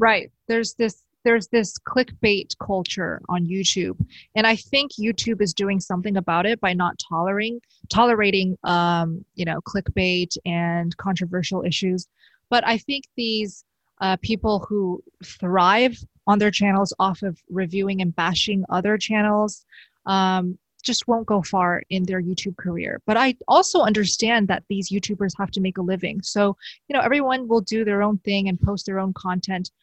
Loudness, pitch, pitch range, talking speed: -22 LUFS, 195 Hz, 185-225 Hz, 165 wpm